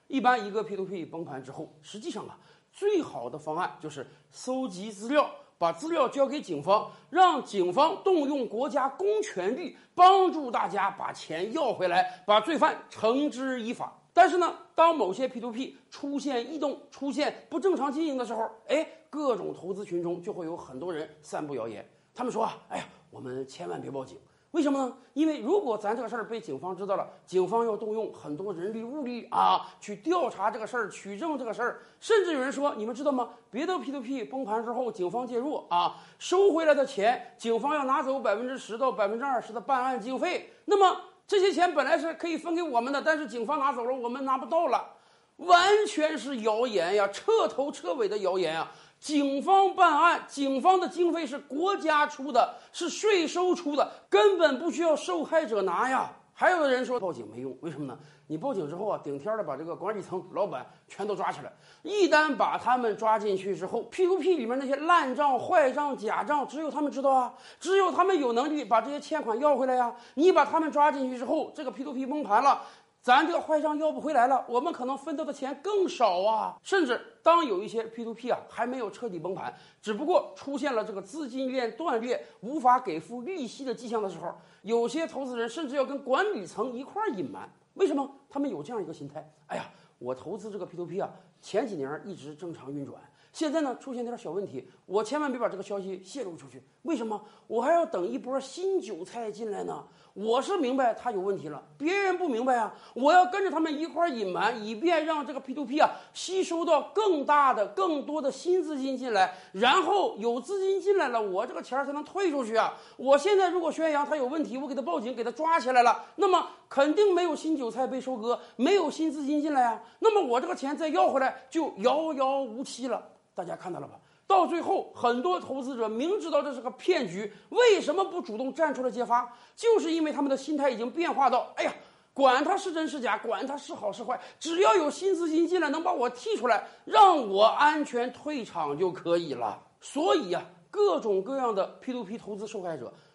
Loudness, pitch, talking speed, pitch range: -28 LUFS, 275 Hz, 315 characters per minute, 230-325 Hz